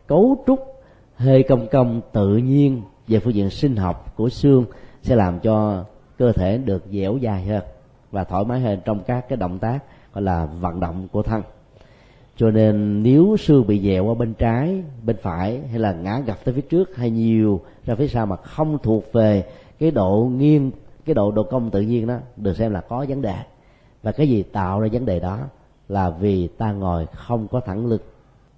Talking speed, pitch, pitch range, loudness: 205 wpm, 115 Hz, 100-130 Hz, -20 LUFS